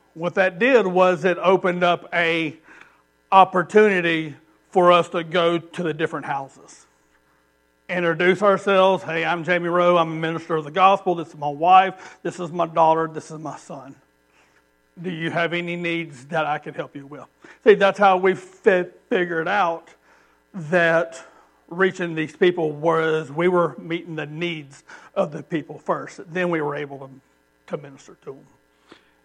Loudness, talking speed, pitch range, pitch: -20 LUFS, 170 wpm, 150-180 Hz, 170 Hz